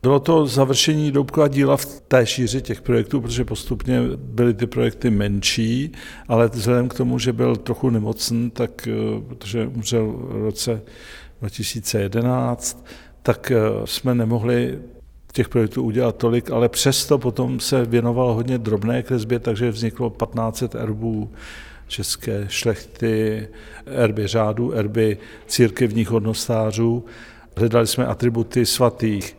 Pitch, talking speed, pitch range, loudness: 120 Hz, 120 wpm, 110-125 Hz, -21 LUFS